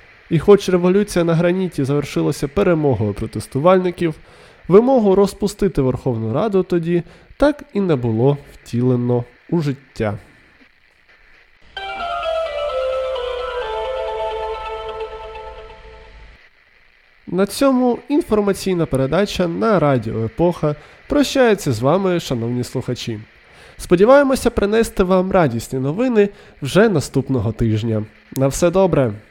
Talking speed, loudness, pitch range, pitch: 90 wpm, -18 LUFS, 135-220 Hz, 180 Hz